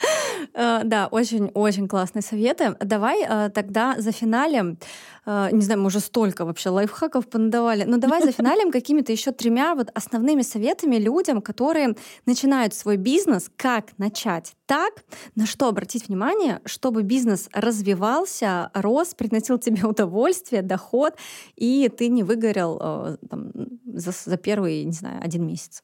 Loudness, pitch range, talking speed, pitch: -22 LUFS, 205-255 Hz, 135 wpm, 225 Hz